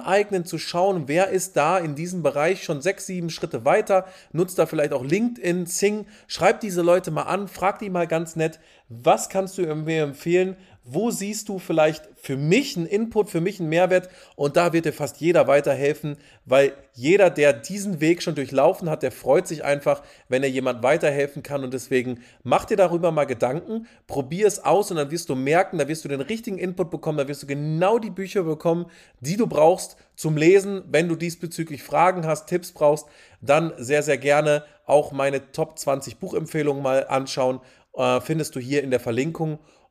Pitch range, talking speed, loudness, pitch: 145-185 Hz, 195 wpm, -23 LUFS, 160 Hz